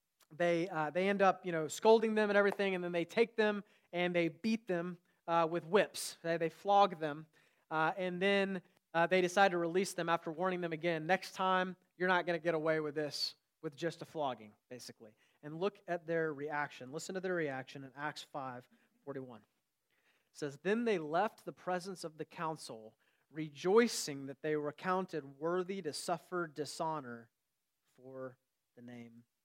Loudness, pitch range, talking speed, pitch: -36 LUFS, 150-185 Hz, 185 wpm, 165 Hz